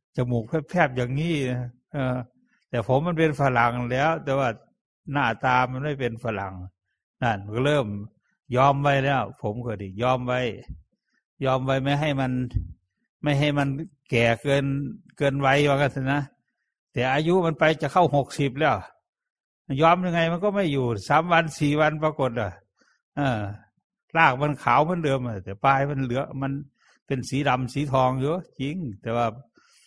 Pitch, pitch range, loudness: 135 Hz, 125-150 Hz, -24 LUFS